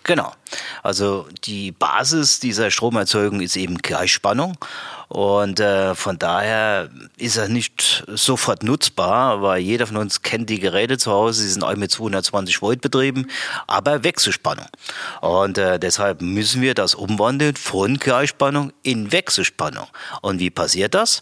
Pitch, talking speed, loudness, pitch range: 105 Hz, 145 wpm, -19 LUFS, 100-130 Hz